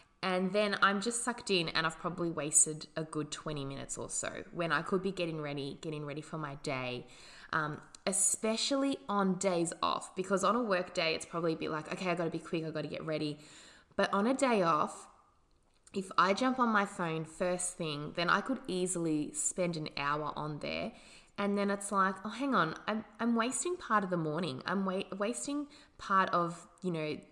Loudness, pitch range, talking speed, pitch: -33 LUFS, 160-200 Hz, 205 wpm, 180 Hz